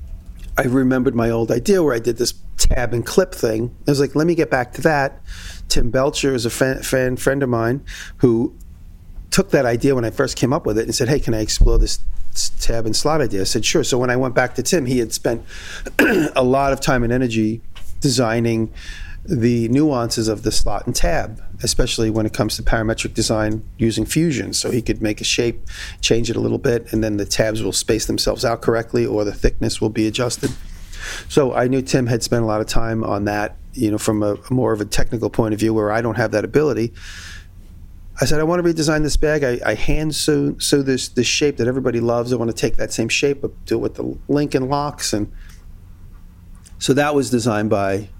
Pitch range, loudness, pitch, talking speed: 105-130 Hz, -19 LUFS, 115 Hz, 230 wpm